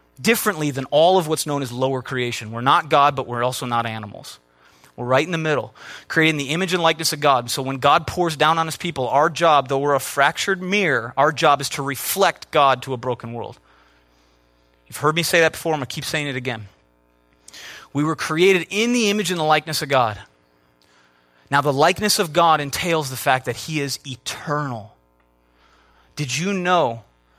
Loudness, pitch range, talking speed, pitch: -20 LUFS, 115-160 Hz, 200 wpm, 140 Hz